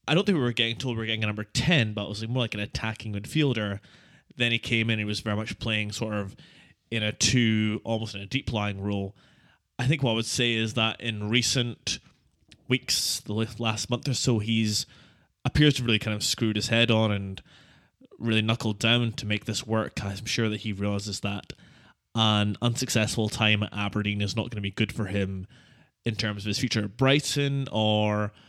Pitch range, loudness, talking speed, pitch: 105-120 Hz, -26 LUFS, 215 wpm, 110 Hz